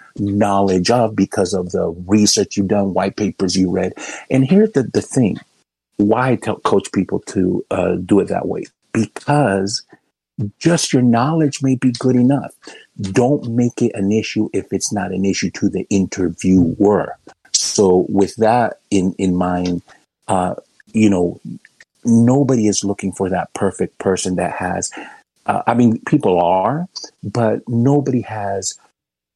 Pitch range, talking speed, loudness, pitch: 95-120 Hz, 155 wpm, -17 LUFS, 105 Hz